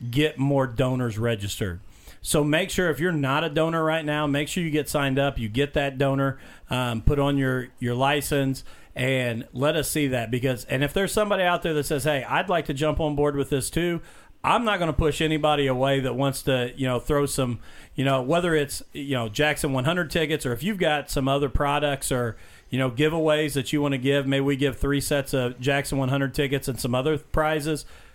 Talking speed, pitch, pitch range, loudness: 225 wpm, 140 Hz, 130-155 Hz, -24 LUFS